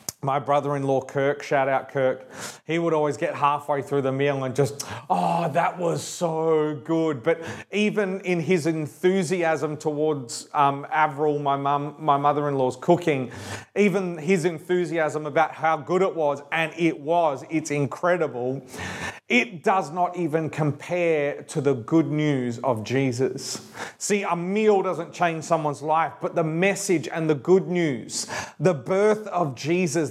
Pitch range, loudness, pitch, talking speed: 140-175 Hz, -24 LUFS, 155 Hz, 155 wpm